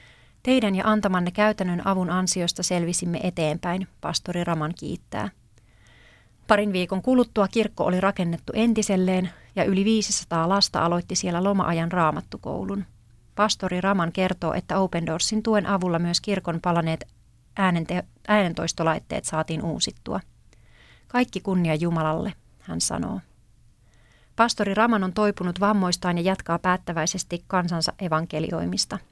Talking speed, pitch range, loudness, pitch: 115 wpm, 160-195 Hz, -24 LUFS, 180 Hz